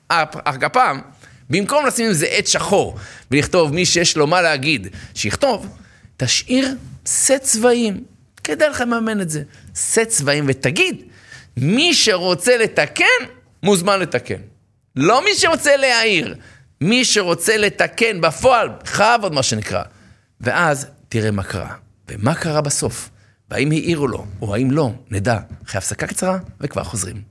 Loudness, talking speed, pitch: -17 LUFS, 140 wpm, 150 Hz